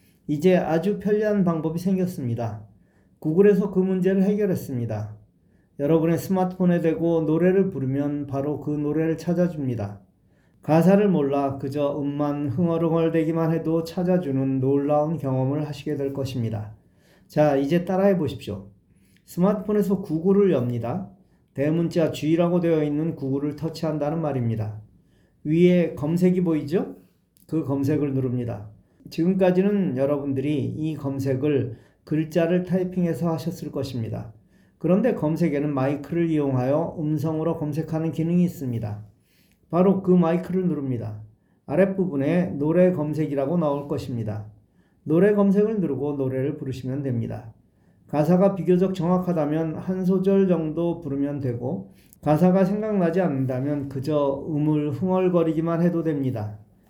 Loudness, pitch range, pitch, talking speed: -23 LUFS, 135-175 Hz, 155 Hz, 325 characters per minute